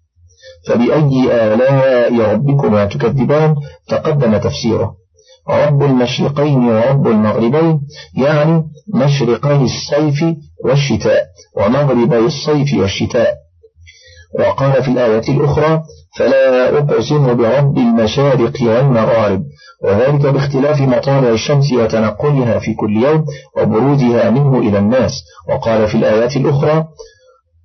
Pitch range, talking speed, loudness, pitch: 115-150 Hz, 90 wpm, -13 LUFS, 135 Hz